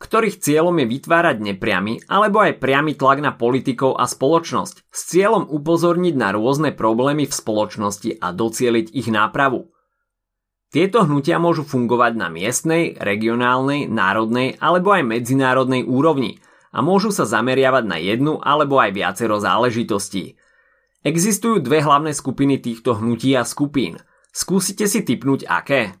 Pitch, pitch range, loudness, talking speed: 135 Hz, 115-165 Hz, -18 LUFS, 135 wpm